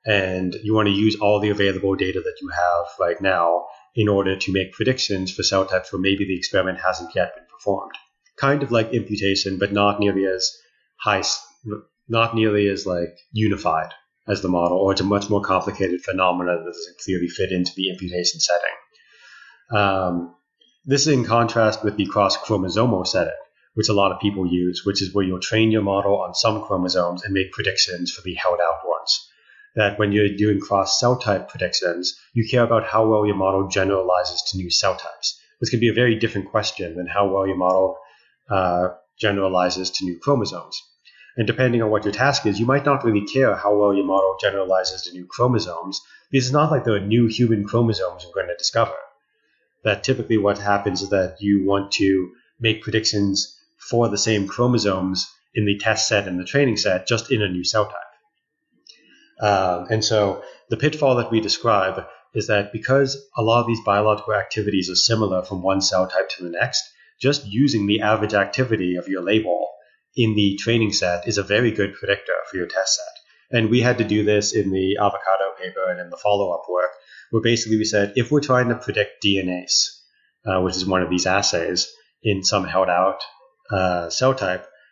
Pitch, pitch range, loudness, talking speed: 100 Hz, 95-115 Hz, -21 LUFS, 200 wpm